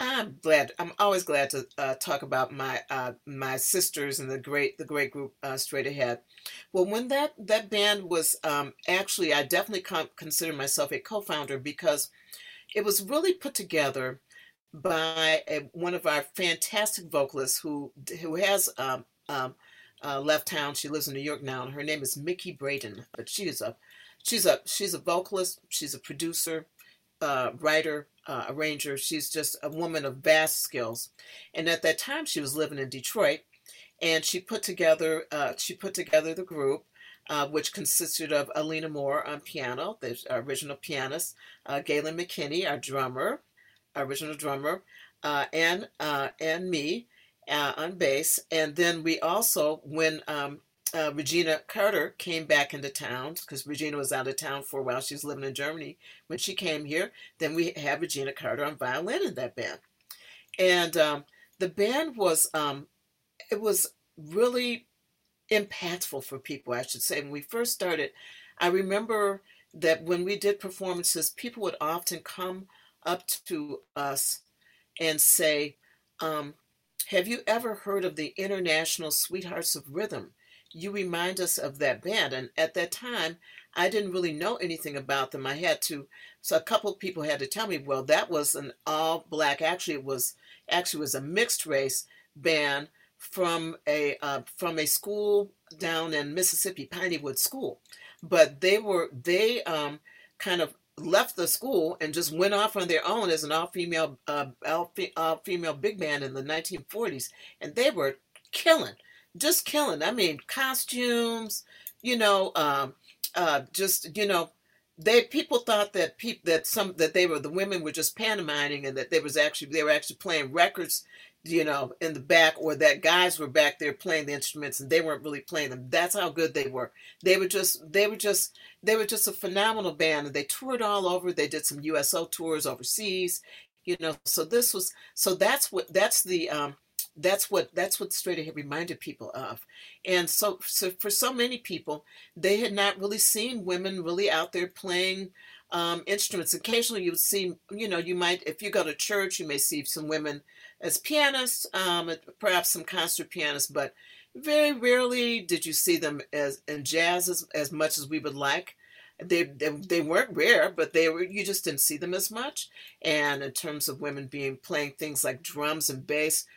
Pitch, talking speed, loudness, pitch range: 165 Hz, 185 wpm, -28 LUFS, 150-195 Hz